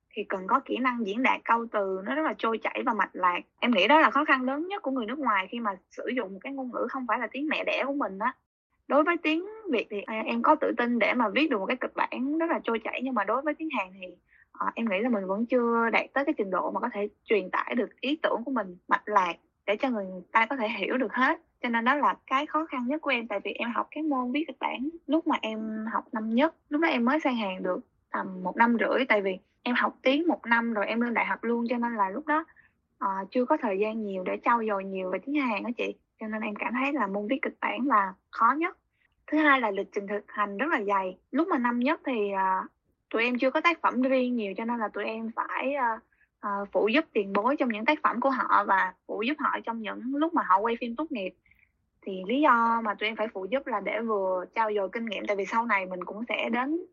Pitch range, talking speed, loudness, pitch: 205-280 Hz, 280 wpm, -28 LUFS, 235 Hz